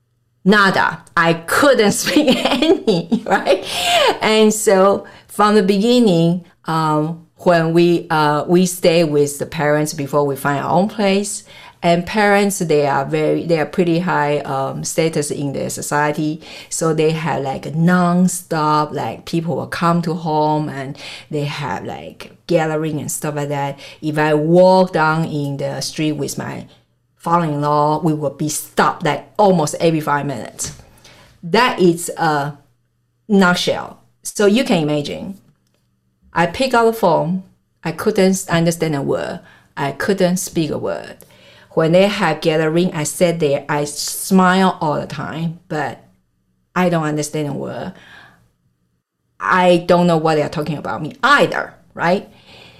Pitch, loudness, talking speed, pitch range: 160 Hz, -17 LUFS, 150 wpm, 145-180 Hz